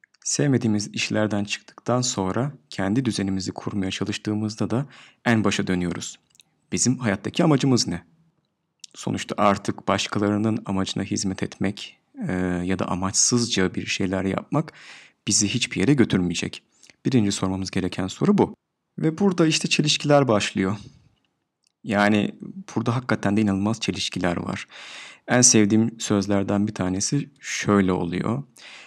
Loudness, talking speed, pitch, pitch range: -23 LUFS, 120 wpm, 105 Hz, 95-125 Hz